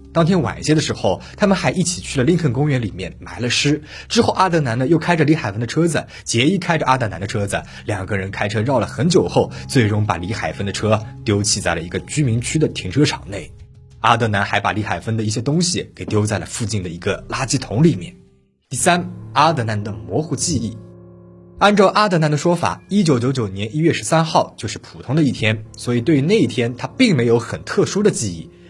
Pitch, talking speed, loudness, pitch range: 120 Hz, 335 characters per minute, -18 LUFS, 105-155 Hz